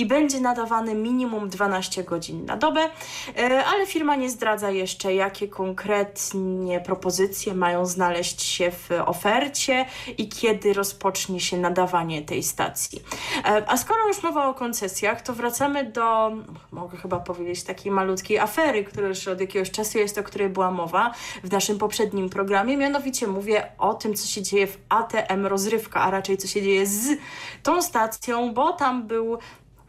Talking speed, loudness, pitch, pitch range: 155 wpm, -24 LUFS, 205 Hz, 190-240 Hz